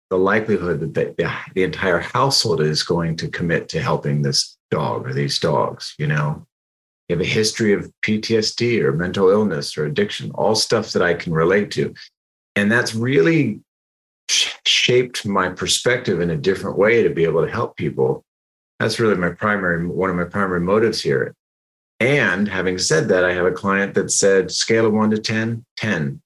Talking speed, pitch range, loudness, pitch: 185 wpm, 75-110 Hz, -19 LUFS, 95 Hz